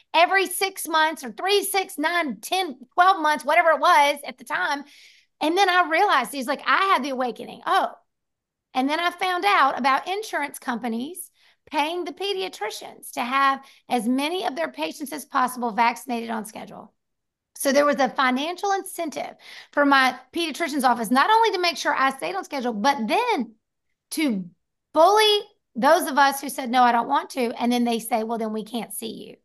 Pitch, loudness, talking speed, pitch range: 290 Hz, -22 LUFS, 190 wpm, 250-350 Hz